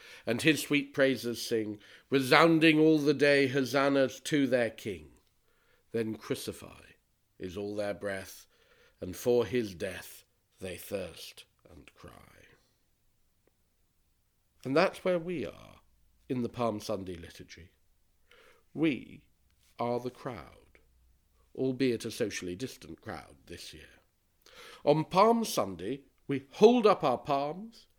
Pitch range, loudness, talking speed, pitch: 90-140 Hz, -29 LUFS, 120 wpm, 115 Hz